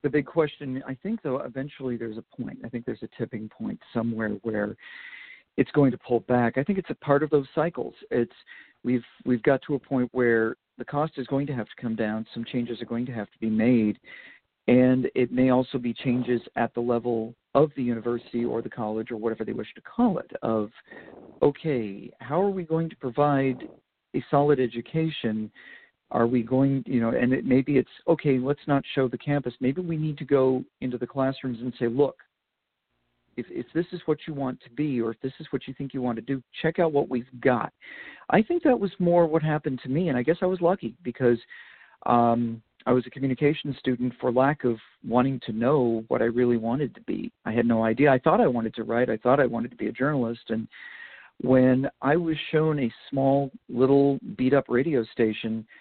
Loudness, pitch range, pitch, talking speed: -26 LUFS, 120-145 Hz, 130 Hz, 220 wpm